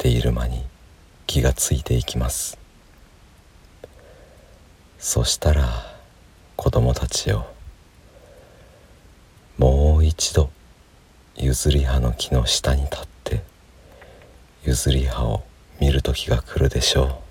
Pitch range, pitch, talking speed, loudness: 60-80 Hz, 70 Hz, 185 characters per minute, -21 LUFS